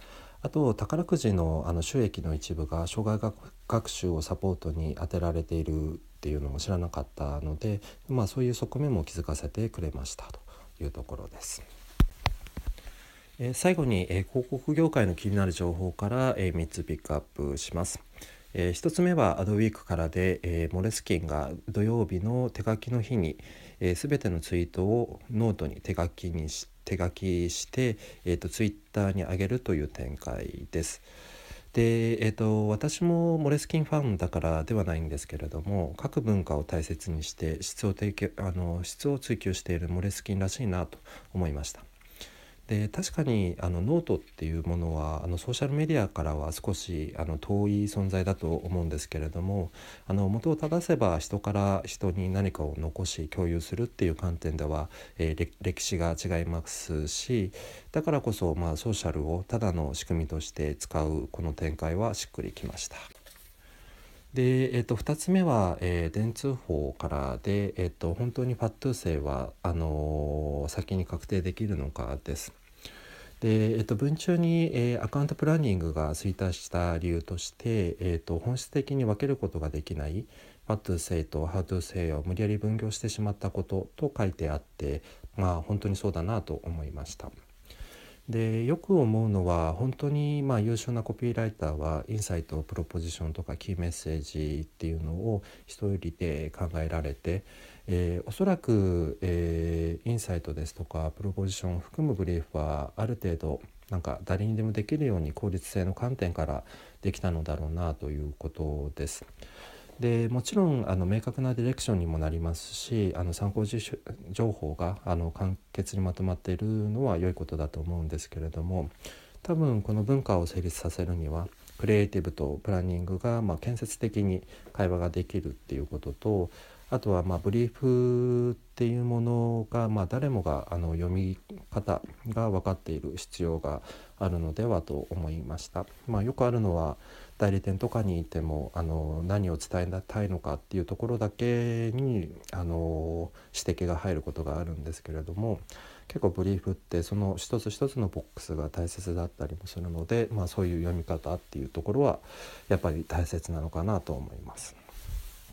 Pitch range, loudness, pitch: 80-110 Hz, -31 LUFS, 90 Hz